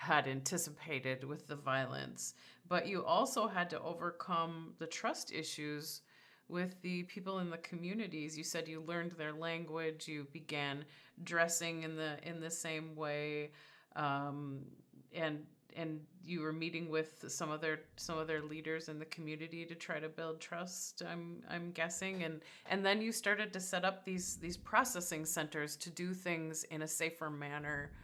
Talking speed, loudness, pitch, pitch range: 165 wpm, -40 LUFS, 160 Hz, 155-175 Hz